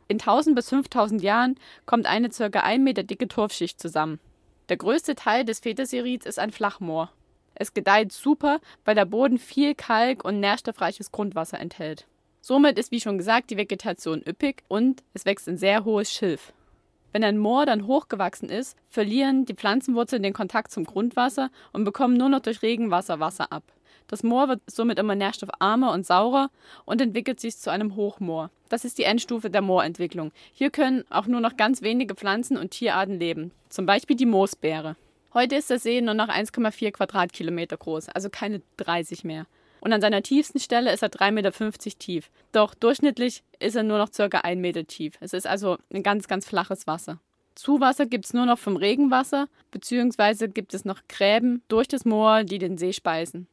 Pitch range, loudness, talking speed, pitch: 190-245 Hz, -24 LUFS, 185 wpm, 215 Hz